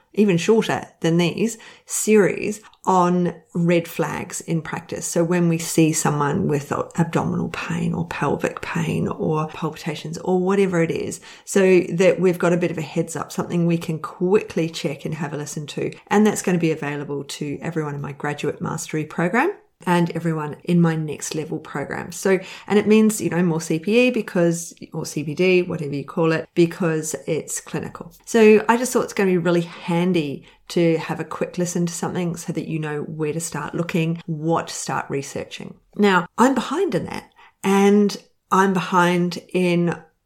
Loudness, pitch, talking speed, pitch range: -21 LUFS, 170 Hz, 185 wpm, 160-190 Hz